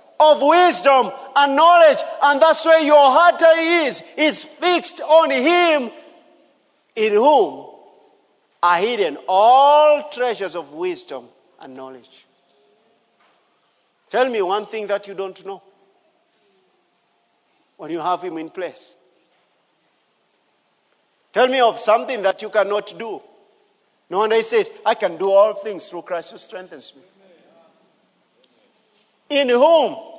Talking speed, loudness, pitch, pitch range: 120 wpm, -16 LUFS, 280 Hz, 195-325 Hz